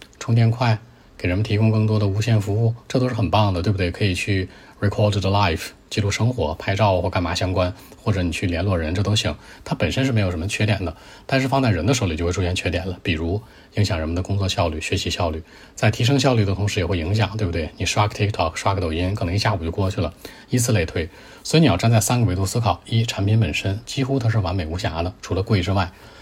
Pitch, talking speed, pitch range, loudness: 100 Hz, 400 characters per minute, 90-110 Hz, -21 LUFS